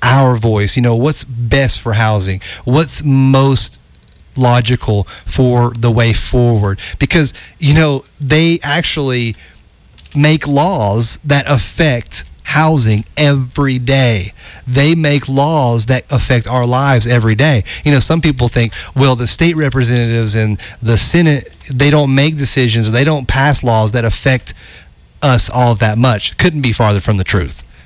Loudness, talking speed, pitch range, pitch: -12 LUFS, 145 wpm, 110-140 Hz, 125 Hz